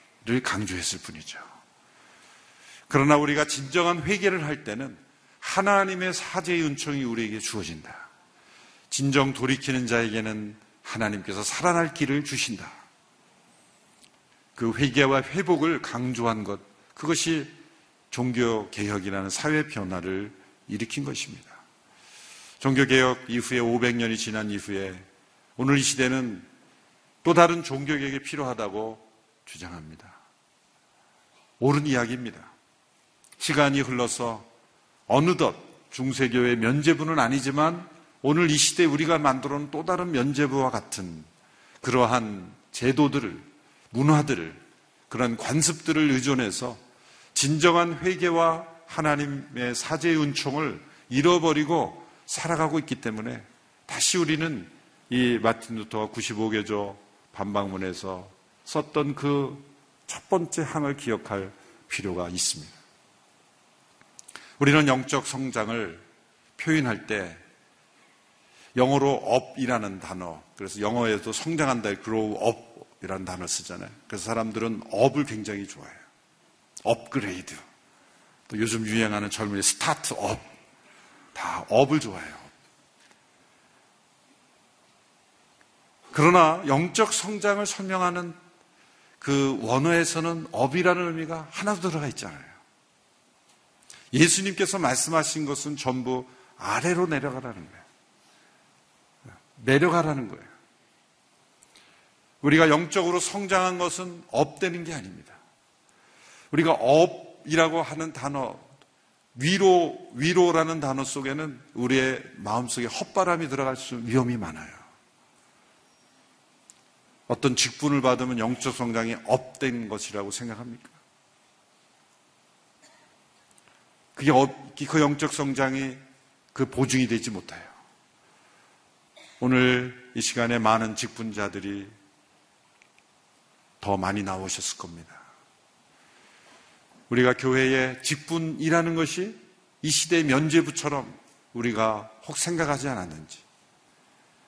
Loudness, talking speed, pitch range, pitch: -25 LUFS, 245 characters per minute, 115-155 Hz, 130 Hz